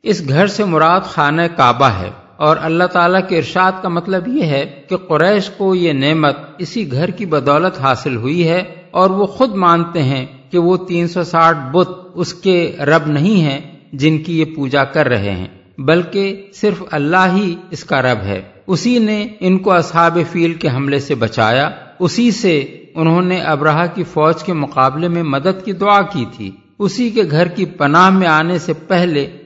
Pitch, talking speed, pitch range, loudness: 170 Hz, 185 wpm, 145-185 Hz, -14 LUFS